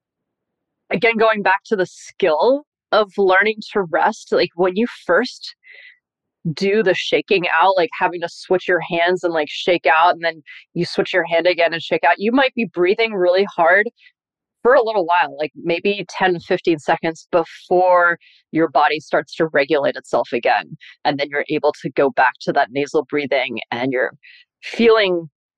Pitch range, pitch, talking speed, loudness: 165-215 Hz, 180 Hz, 175 wpm, -18 LUFS